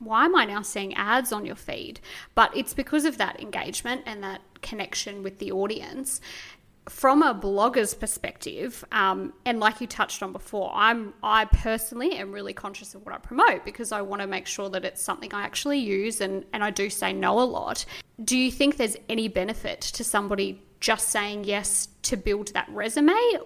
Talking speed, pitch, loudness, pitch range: 195 wpm, 215 Hz, -26 LUFS, 200-245 Hz